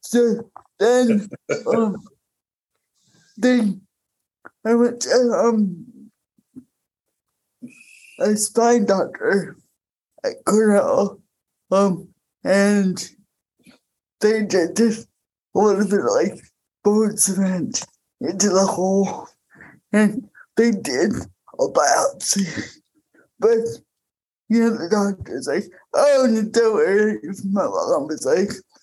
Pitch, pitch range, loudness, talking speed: 220 Hz, 200-240 Hz, -20 LUFS, 100 wpm